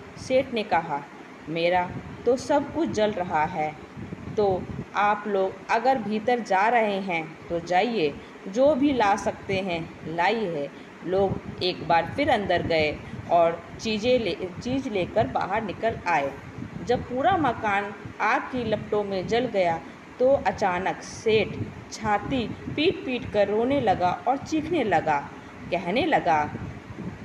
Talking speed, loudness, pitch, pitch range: 140 wpm, -25 LUFS, 205 Hz, 170-245 Hz